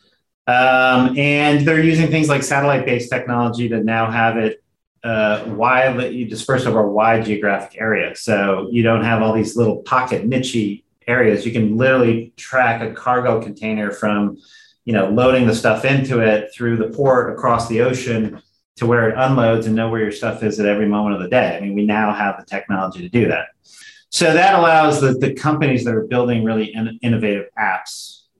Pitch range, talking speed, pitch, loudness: 110-130 Hz, 190 wpm, 115 Hz, -17 LUFS